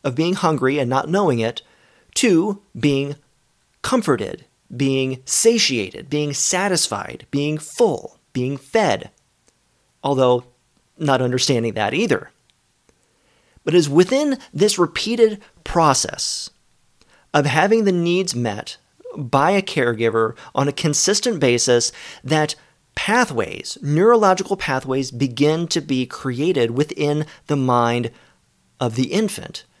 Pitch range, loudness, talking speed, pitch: 130-180 Hz, -19 LUFS, 115 wpm, 145 Hz